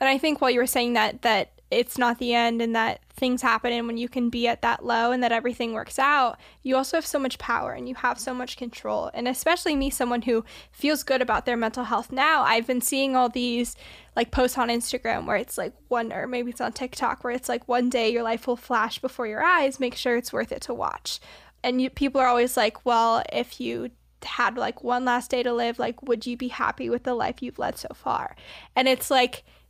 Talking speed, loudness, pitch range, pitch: 245 wpm, -25 LUFS, 235-260 Hz, 245 Hz